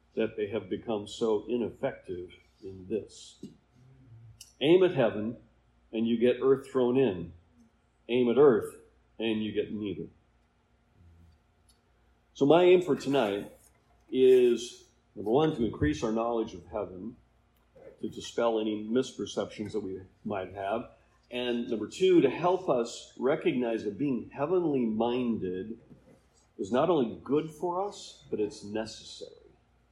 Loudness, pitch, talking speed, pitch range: -29 LUFS, 125 Hz, 130 wpm, 110-180 Hz